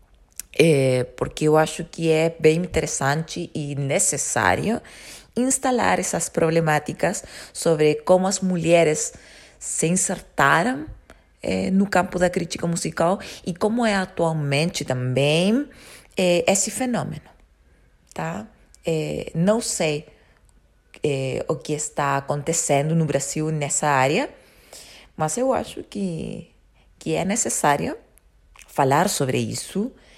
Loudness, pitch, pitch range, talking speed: -22 LUFS, 165 Hz, 150-185 Hz, 110 wpm